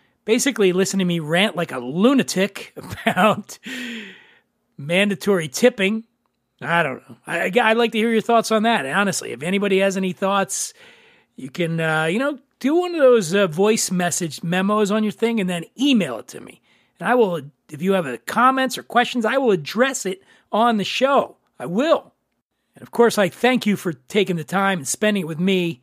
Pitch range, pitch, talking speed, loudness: 175-235 Hz, 200 Hz, 200 wpm, -20 LUFS